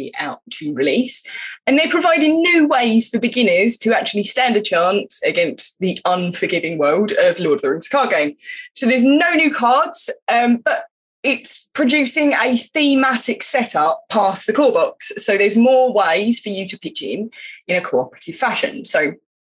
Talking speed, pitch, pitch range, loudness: 170 wpm, 245 Hz, 210-300 Hz, -16 LUFS